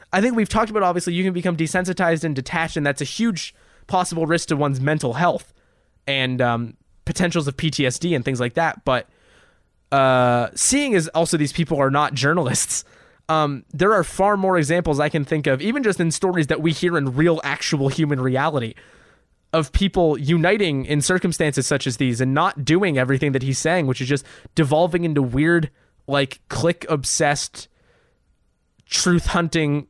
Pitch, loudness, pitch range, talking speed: 160 Hz, -20 LUFS, 140-175 Hz, 175 wpm